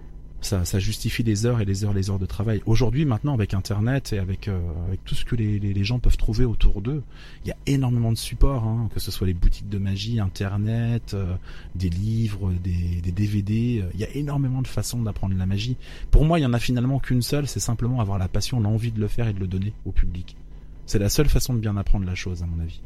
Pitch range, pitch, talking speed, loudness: 95-120 Hz, 105 Hz, 260 wpm, -25 LUFS